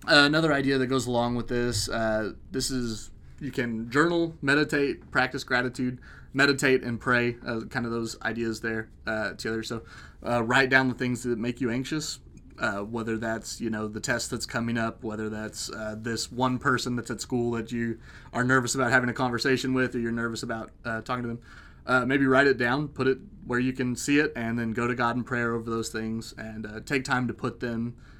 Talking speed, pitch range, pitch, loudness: 220 wpm, 115-130 Hz, 120 Hz, -27 LUFS